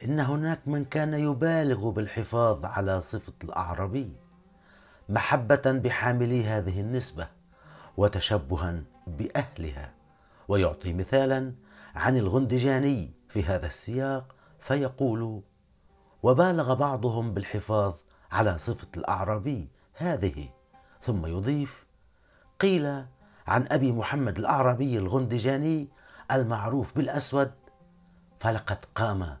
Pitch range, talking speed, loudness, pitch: 95-135 Hz, 85 wpm, -28 LUFS, 115 Hz